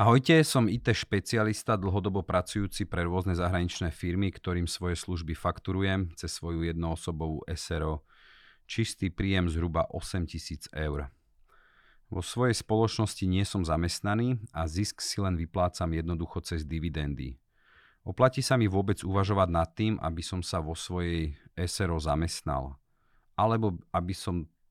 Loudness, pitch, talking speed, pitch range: -30 LUFS, 90 Hz, 130 wpm, 85-100 Hz